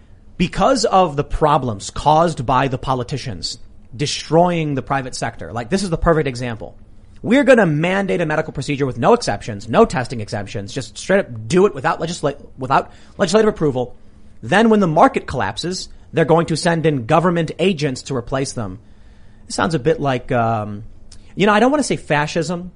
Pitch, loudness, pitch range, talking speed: 145 Hz, -18 LUFS, 120-170 Hz, 185 wpm